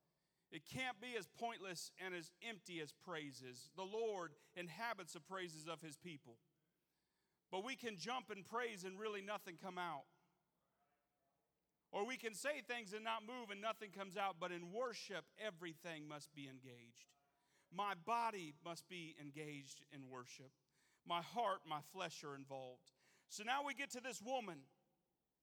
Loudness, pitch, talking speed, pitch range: -49 LUFS, 180 Hz, 160 wpm, 150-215 Hz